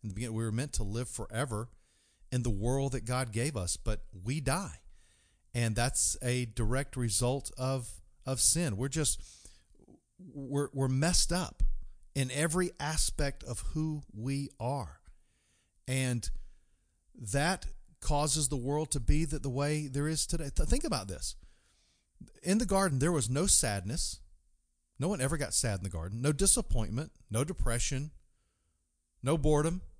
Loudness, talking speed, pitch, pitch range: -32 LUFS, 150 wpm, 125 Hz, 100-145 Hz